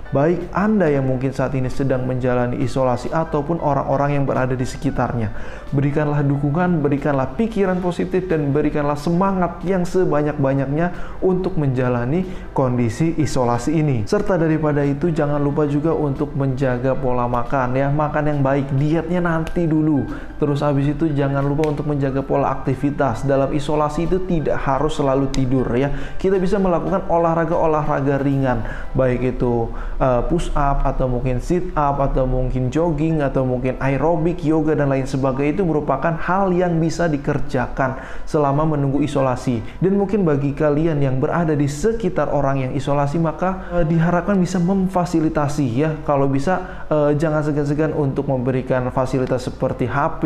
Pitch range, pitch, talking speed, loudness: 135-165 Hz, 145 Hz, 150 wpm, -20 LUFS